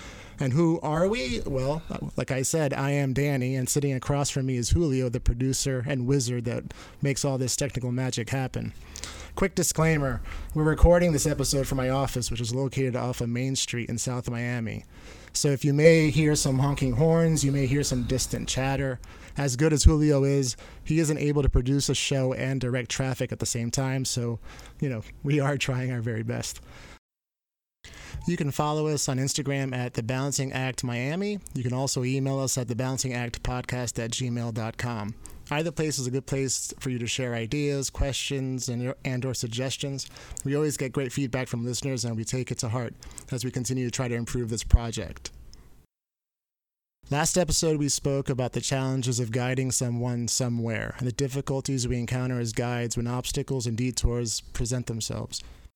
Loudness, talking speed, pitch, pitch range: -27 LUFS, 185 wpm, 130 Hz, 120-140 Hz